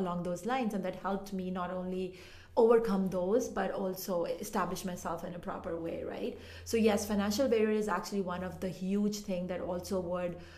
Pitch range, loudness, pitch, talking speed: 180-210 Hz, -34 LUFS, 185 Hz, 195 wpm